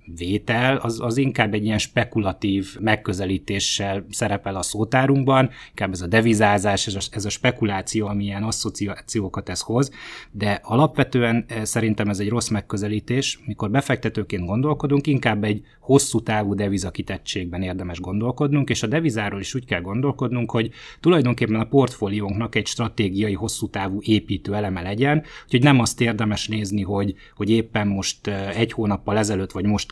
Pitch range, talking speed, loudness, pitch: 100-120 Hz, 150 wpm, -22 LUFS, 110 Hz